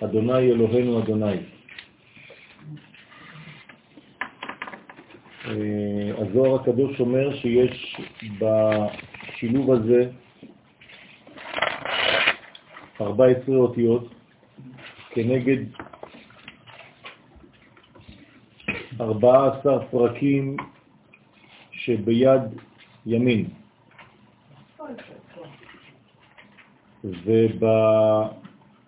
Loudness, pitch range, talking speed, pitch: -22 LUFS, 110-130 Hz, 35 wpm, 120 Hz